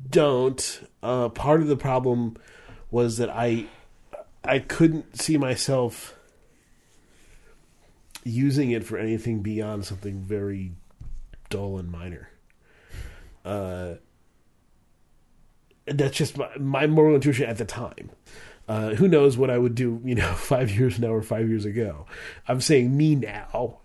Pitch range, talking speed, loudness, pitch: 105-135 Hz, 135 wpm, -24 LUFS, 120 Hz